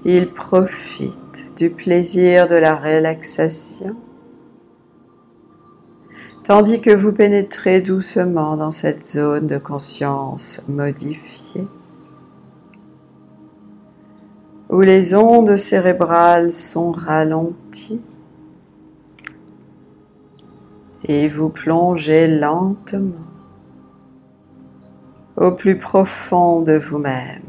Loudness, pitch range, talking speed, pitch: -15 LUFS, 145-185 Hz, 70 wpm, 165 Hz